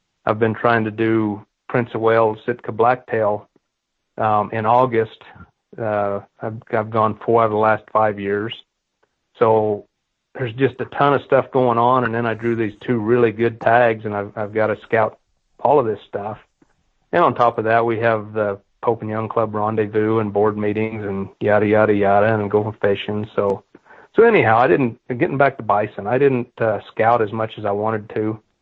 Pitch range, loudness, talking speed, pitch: 105-115 Hz, -19 LUFS, 195 wpm, 110 Hz